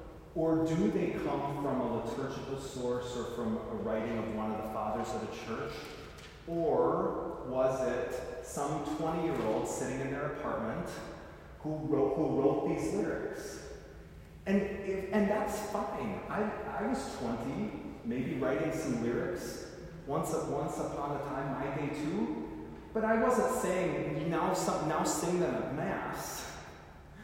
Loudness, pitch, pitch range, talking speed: -34 LUFS, 150 Hz, 125-185 Hz, 145 wpm